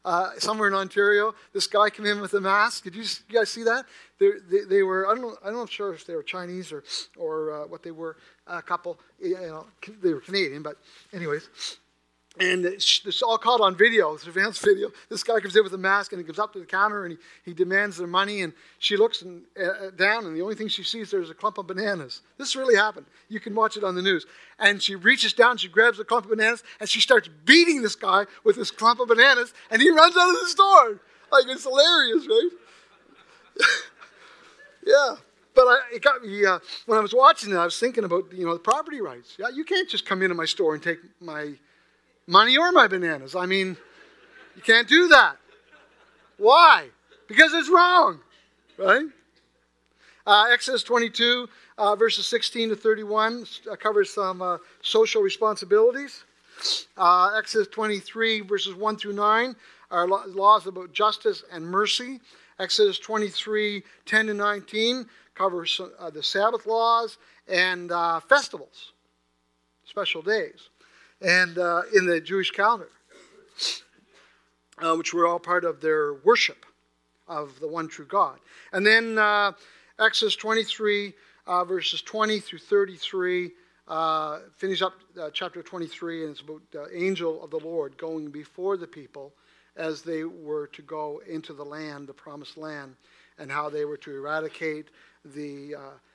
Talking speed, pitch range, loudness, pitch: 180 wpm, 170-230 Hz, -22 LUFS, 200 Hz